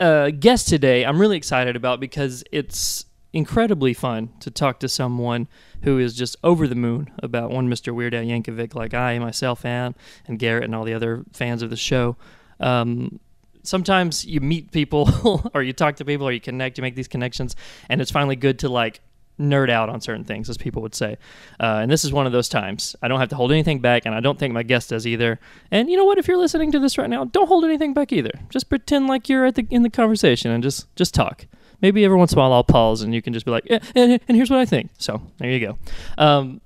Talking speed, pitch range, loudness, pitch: 250 wpm, 120-170 Hz, -20 LUFS, 130 Hz